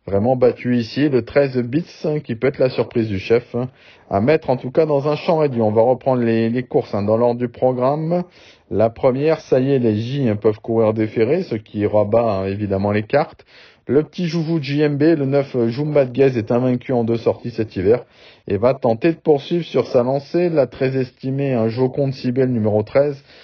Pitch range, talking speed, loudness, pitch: 115-145 Hz, 220 wpm, -18 LUFS, 125 Hz